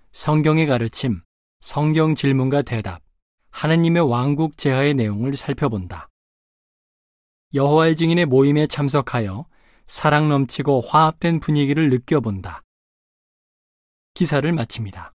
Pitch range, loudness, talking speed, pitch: 115-155 Hz, -19 LUFS, 260 characters per minute, 140 Hz